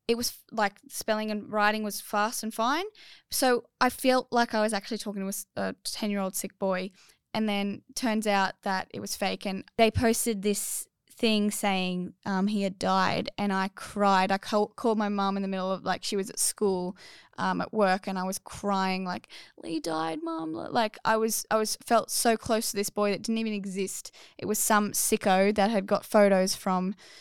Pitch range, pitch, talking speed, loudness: 195-220 Hz, 205 Hz, 210 wpm, -28 LUFS